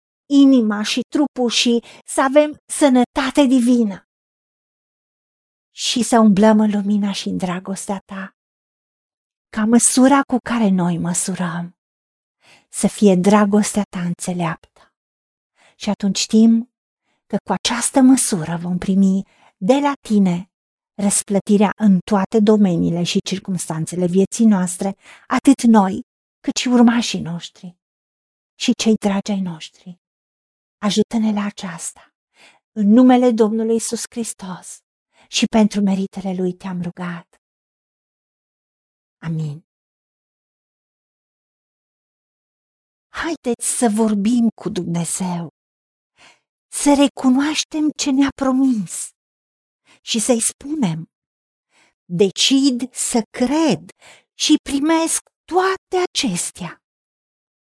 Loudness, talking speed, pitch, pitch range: -17 LUFS, 100 wpm, 210 Hz, 190-250 Hz